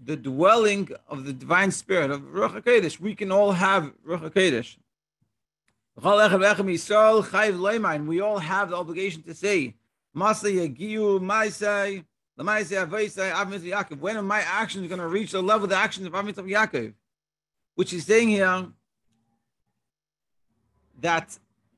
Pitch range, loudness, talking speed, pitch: 160-210 Hz, -24 LUFS, 115 wpm, 195 Hz